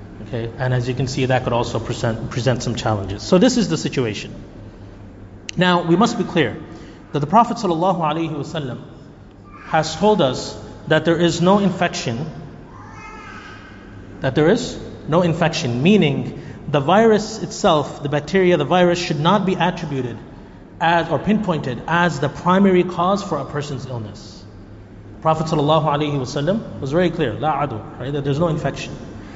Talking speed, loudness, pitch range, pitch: 150 wpm, -19 LUFS, 115-175 Hz, 145 Hz